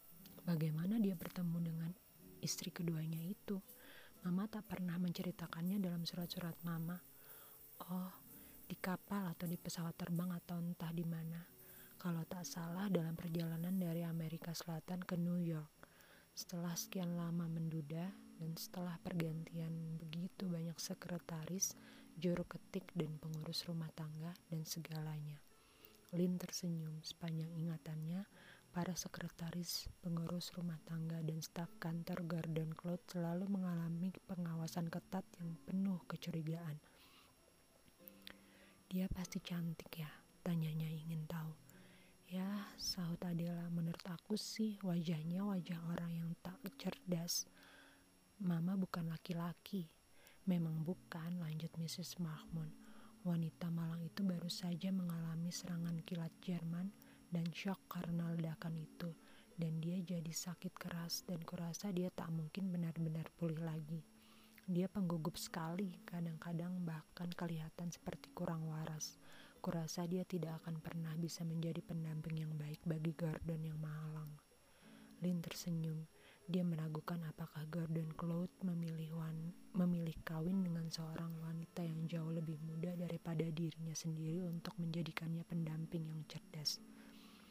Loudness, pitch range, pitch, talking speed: -44 LUFS, 165-180 Hz, 170 Hz, 120 wpm